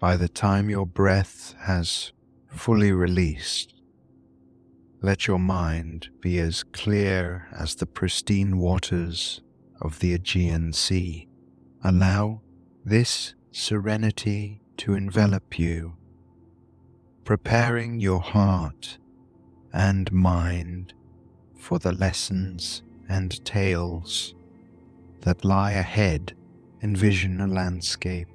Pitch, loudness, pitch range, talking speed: 90 Hz, -25 LUFS, 85-100 Hz, 95 wpm